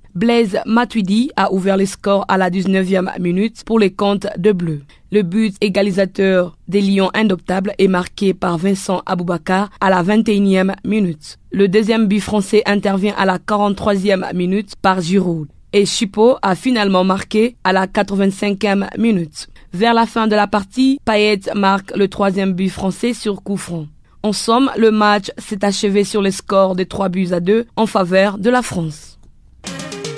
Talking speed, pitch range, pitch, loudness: 165 wpm, 190-215 Hz, 200 Hz, -16 LUFS